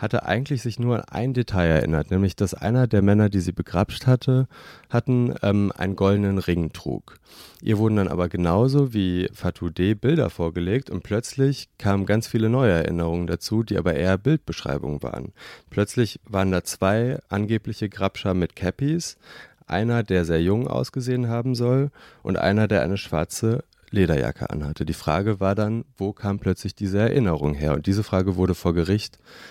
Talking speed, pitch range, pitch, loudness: 170 wpm, 90-115 Hz, 100 Hz, -23 LUFS